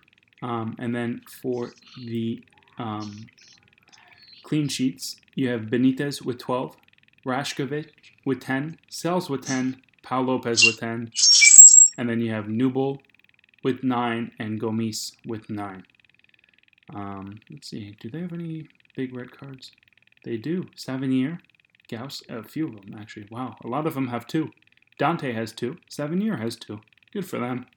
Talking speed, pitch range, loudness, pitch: 150 wpm, 115-135 Hz, -19 LUFS, 125 Hz